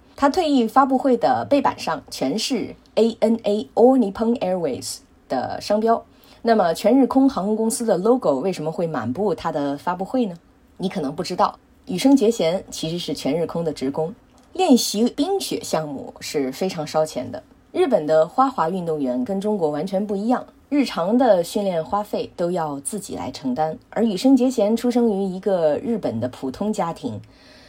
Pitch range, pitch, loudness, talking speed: 165-245 Hz, 205 Hz, -21 LUFS, 300 characters per minute